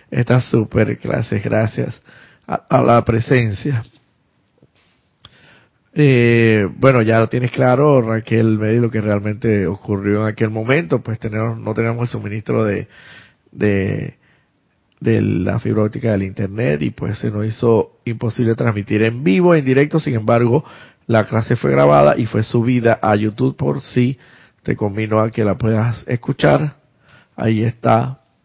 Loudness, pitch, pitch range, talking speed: -17 LUFS, 115 Hz, 110-125 Hz, 150 wpm